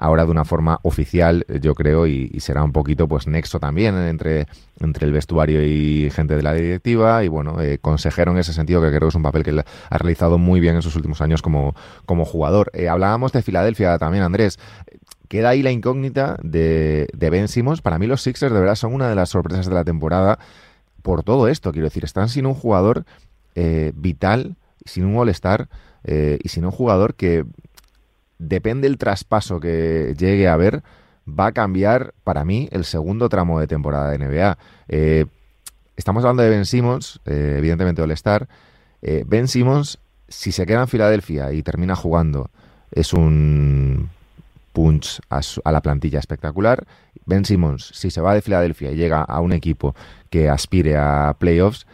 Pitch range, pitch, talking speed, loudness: 75-100 Hz, 85 Hz, 185 wpm, -19 LUFS